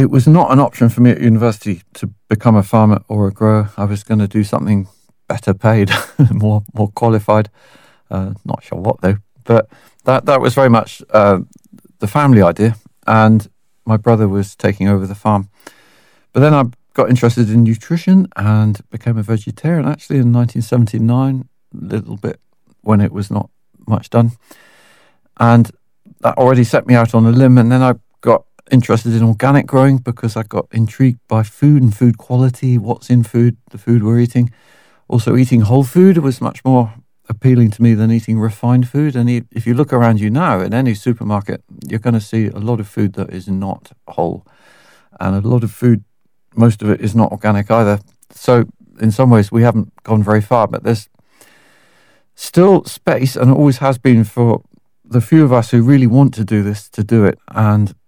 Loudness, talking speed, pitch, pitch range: -13 LUFS, 190 wpm, 115 Hz, 105-125 Hz